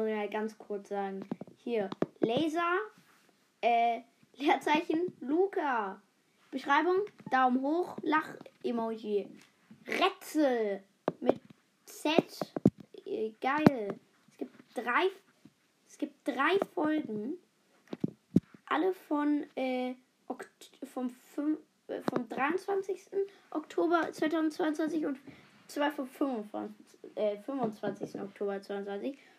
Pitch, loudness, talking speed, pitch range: 290 Hz, -33 LUFS, 85 wpm, 235-350 Hz